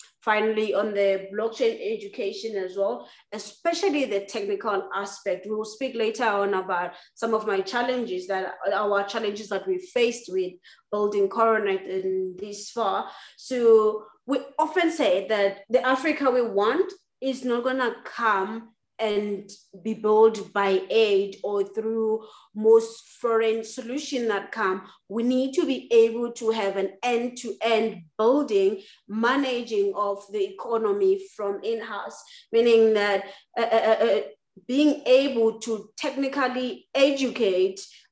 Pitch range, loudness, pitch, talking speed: 200-255 Hz, -25 LUFS, 220 Hz, 135 wpm